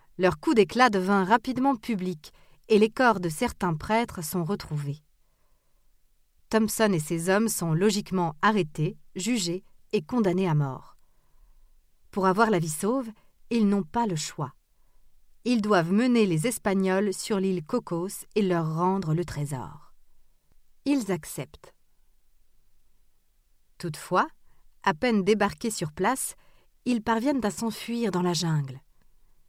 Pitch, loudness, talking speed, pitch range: 195 Hz, -26 LUFS, 130 wpm, 175-225 Hz